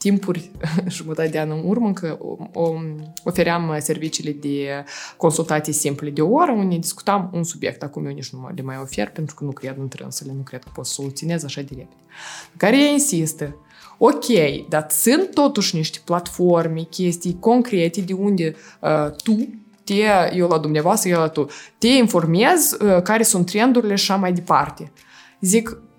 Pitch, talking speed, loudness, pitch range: 170 Hz, 175 wpm, -19 LUFS, 155-200 Hz